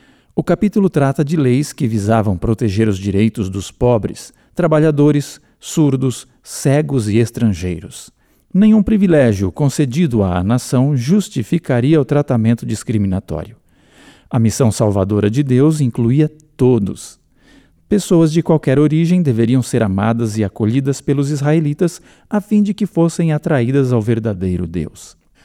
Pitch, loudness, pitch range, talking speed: 130 Hz, -15 LUFS, 110-155 Hz, 125 wpm